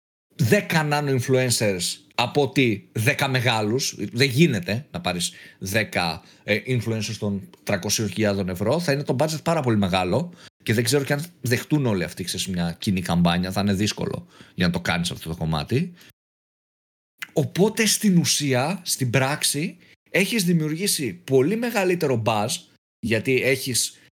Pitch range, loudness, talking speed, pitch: 100-155 Hz, -23 LUFS, 140 wpm, 130 Hz